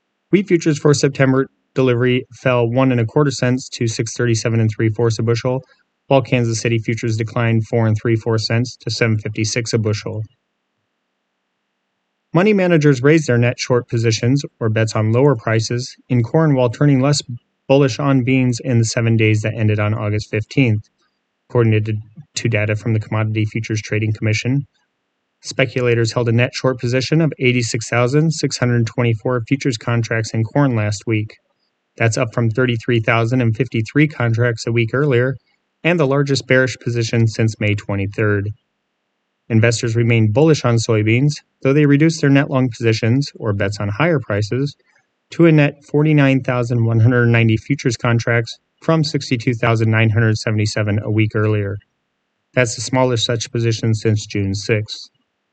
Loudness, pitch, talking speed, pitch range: -17 LUFS, 120 Hz, 150 wpm, 110-135 Hz